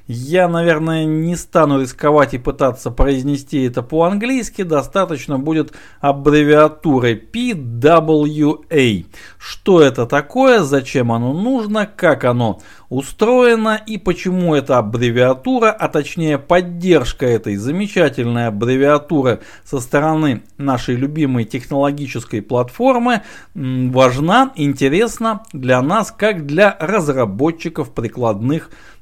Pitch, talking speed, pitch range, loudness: 150 Hz, 95 wpm, 130-175 Hz, -15 LUFS